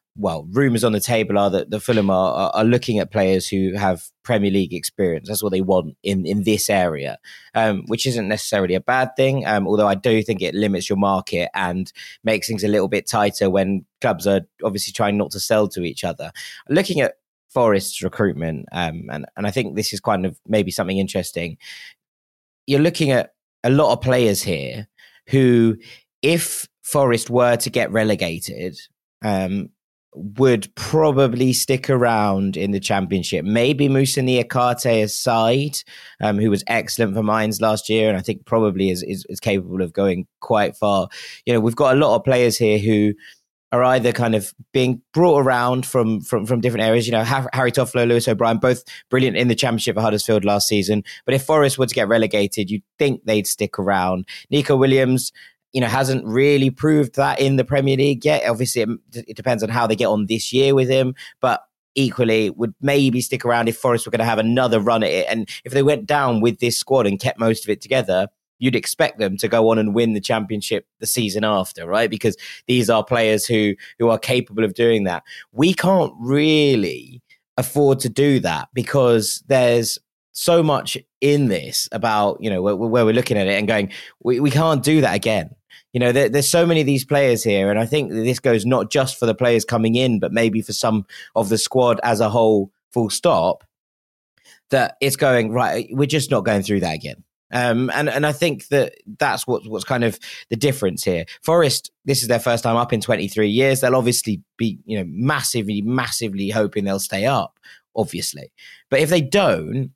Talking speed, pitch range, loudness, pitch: 200 wpm, 105-130 Hz, -19 LUFS, 115 Hz